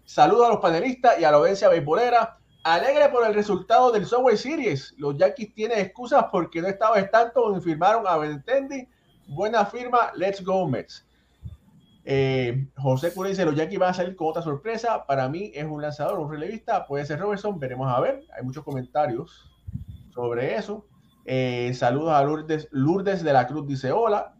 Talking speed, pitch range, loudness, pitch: 180 wpm, 145-220 Hz, -23 LUFS, 180 Hz